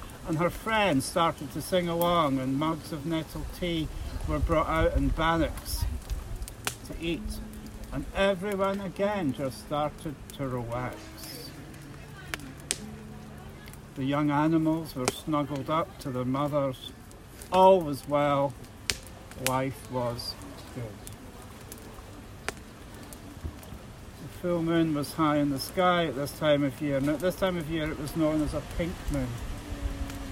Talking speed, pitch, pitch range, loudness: 135 wpm, 140 Hz, 110-160 Hz, -29 LUFS